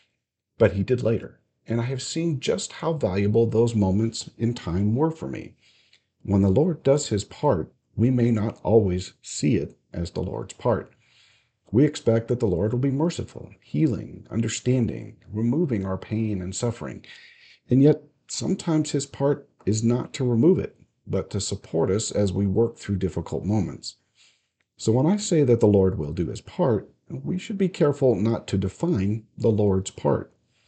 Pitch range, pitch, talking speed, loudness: 100-130 Hz, 115 Hz, 175 wpm, -24 LUFS